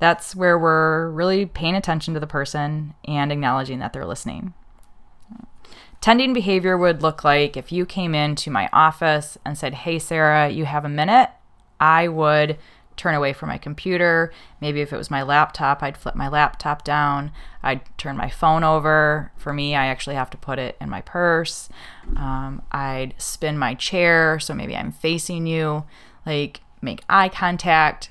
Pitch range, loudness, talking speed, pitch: 145-170 Hz, -20 LUFS, 175 wpm, 155 Hz